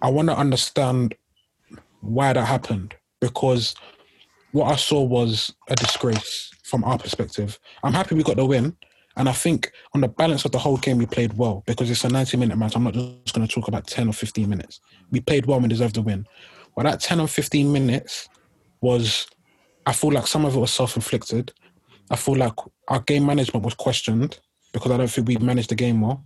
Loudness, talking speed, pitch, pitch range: -22 LUFS, 215 wpm, 125 Hz, 115-135 Hz